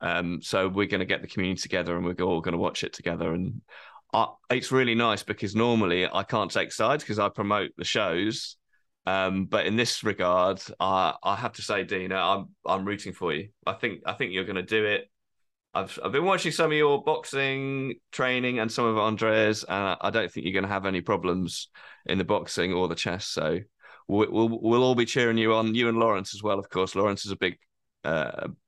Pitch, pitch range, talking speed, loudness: 105 Hz, 95-115 Hz, 230 wpm, -27 LUFS